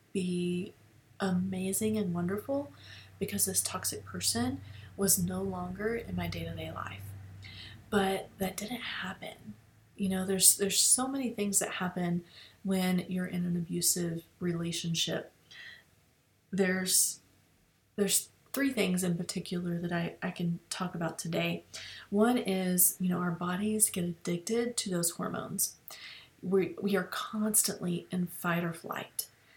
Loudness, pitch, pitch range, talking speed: -31 LUFS, 180 Hz, 170-195 Hz, 135 wpm